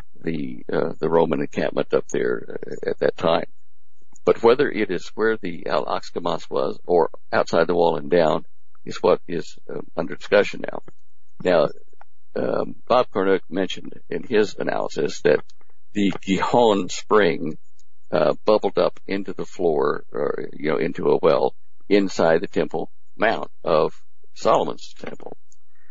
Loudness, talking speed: -22 LUFS, 145 wpm